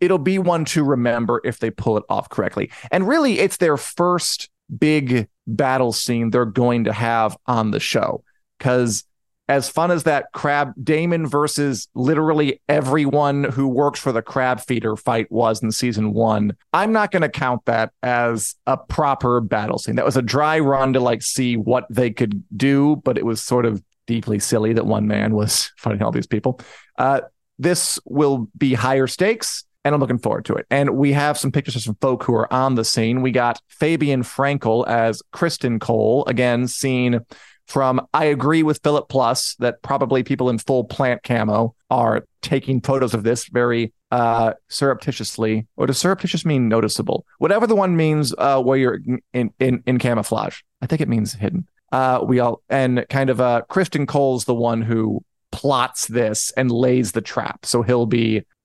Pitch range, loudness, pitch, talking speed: 115-140 Hz, -19 LUFS, 125 Hz, 185 wpm